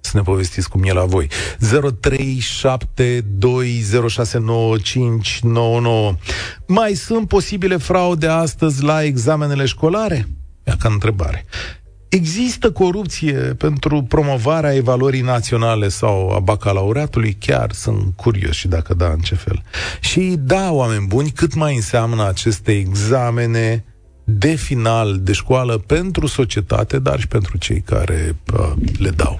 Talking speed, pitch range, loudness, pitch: 120 wpm, 95-140 Hz, -17 LUFS, 115 Hz